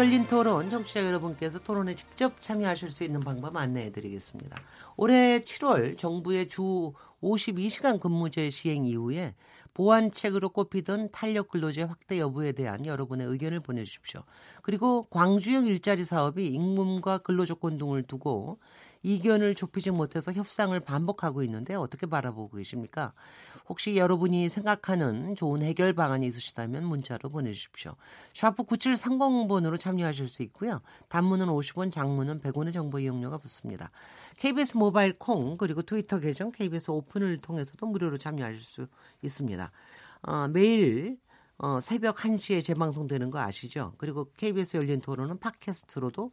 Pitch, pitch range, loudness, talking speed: 170 Hz, 140-200 Hz, -29 LUFS, 350 characters per minute